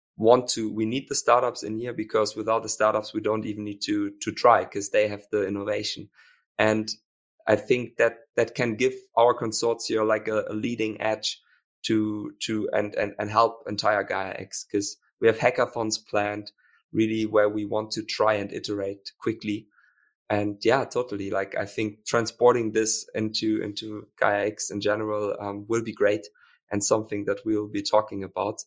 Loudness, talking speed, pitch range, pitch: -26 LUFS, 180 wpm, 105-115 Hz, 110 Hz